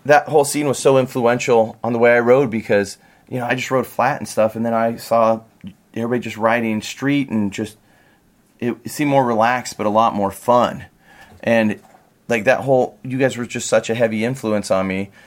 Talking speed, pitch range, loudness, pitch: 210 wpm, 110-125 Hz, -18 LUFS, 115 Hz